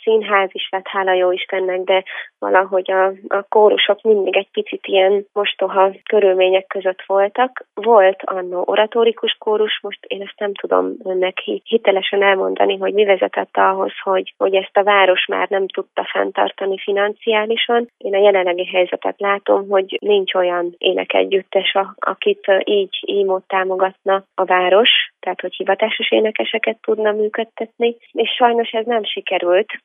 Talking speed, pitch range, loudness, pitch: 145 wpm, 185-215 Hz, -17 LUFS, 195 Hz